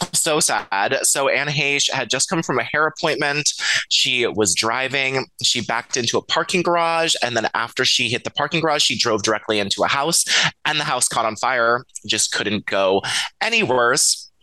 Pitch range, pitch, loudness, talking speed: 115-150 Hz, 130 Hz, -18 LUFS, 190 wpm